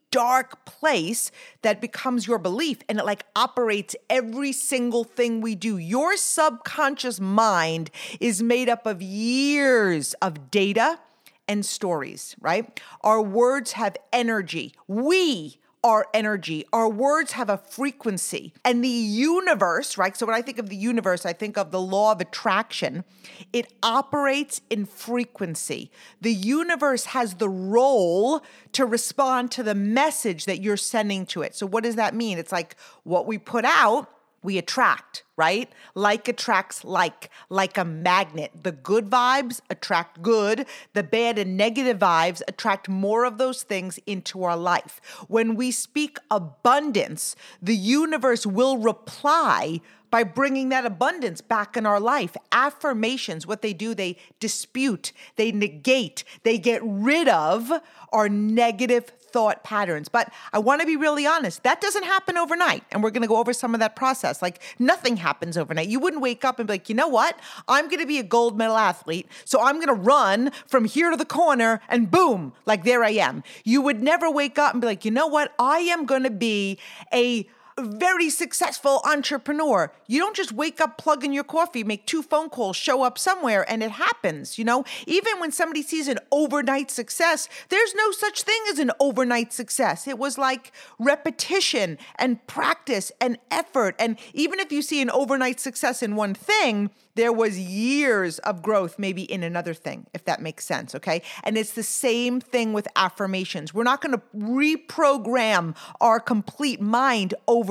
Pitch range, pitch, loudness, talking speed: 205-275 Hz, 235 Hz, -23 LUFS, 175 wpm